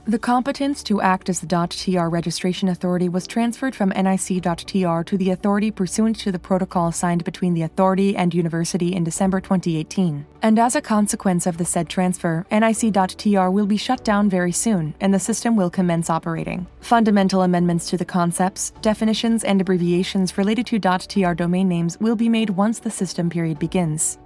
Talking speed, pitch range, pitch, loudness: 175 wpm, 175-210 Hz, 190 Hz, -20 LUFS